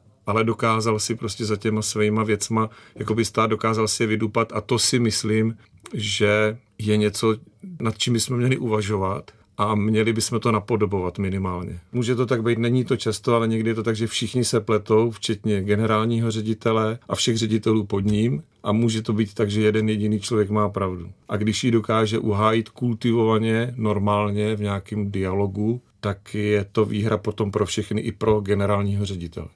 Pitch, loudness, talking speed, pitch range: 110 Hz, -22 LUFS, 180 wpm, 105-115 Hz